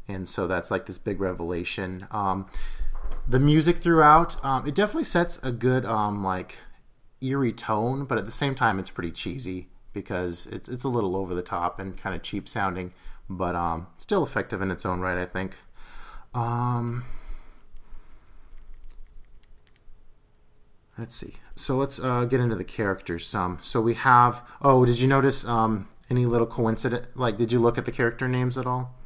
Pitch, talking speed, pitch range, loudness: 110 Hz, 175 wpm, 90-125 Hz, -25 LUFS